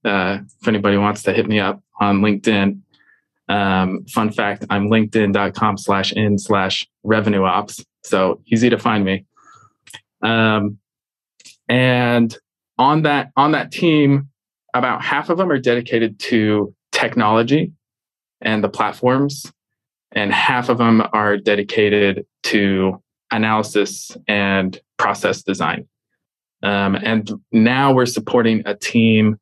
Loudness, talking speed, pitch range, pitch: -17 LUFS, 115 wpm, 100-115 Hz, 110 Hz